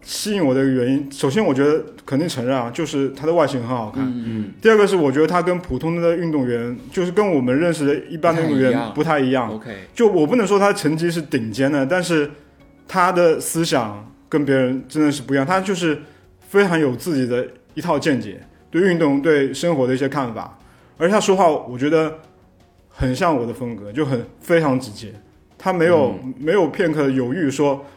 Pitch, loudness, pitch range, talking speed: 140 Hz, -19 LUFS, 125-165 Hz, 305 characters per minute